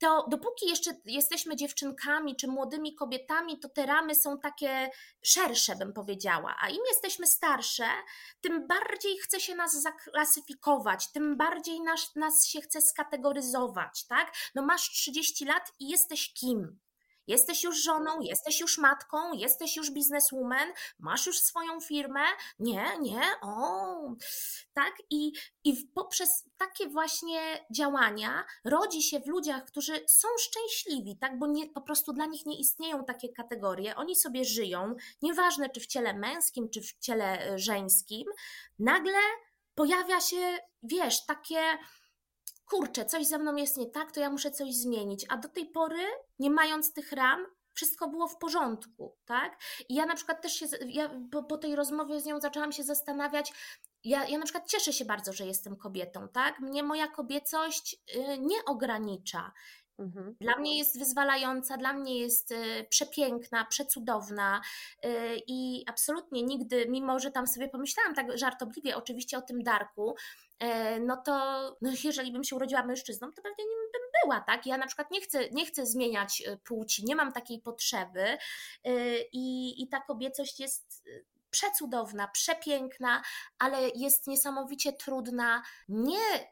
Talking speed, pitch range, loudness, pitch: 150 wpm, 250-320 Hz, -30 LUFS, 285 Hz